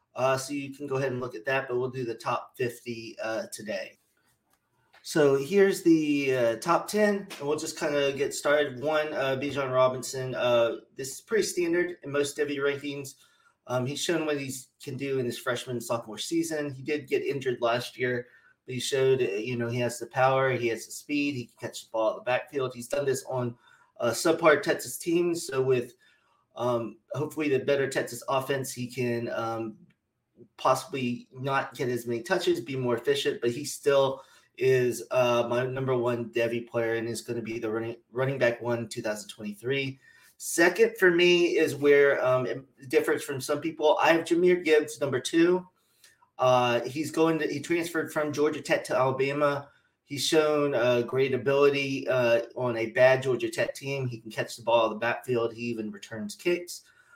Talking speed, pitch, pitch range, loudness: 195 wpm, 135 Hz, 125-160 Hz, -27 LUFS